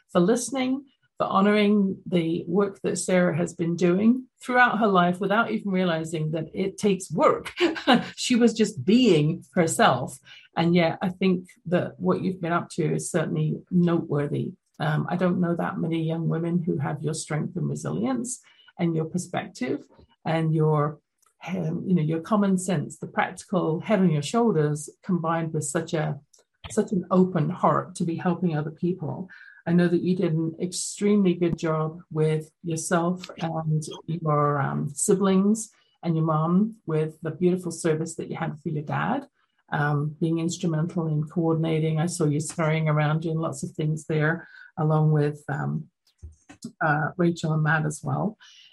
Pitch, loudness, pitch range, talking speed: 170 Hz, -25 LUFS, 155-190 Hz, 165 wpm